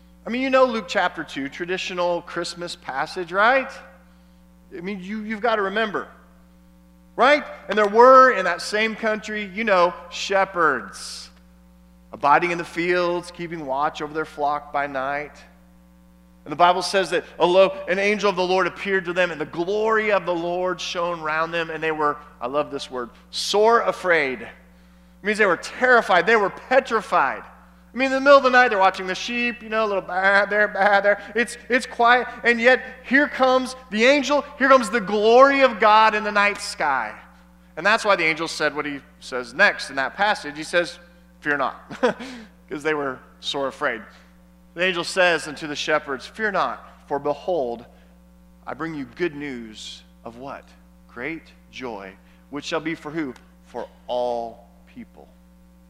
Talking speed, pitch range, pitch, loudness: 180 wpm, 130-215 Hz, 175 Hz, -20 LUFS